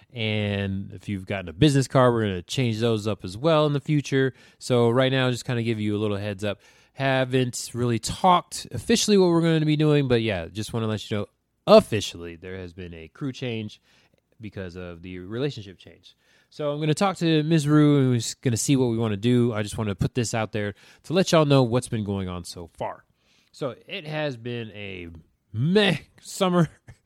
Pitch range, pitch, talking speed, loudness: 100-145 Hz, 120 Hz, 230 wpm, -24 LUFS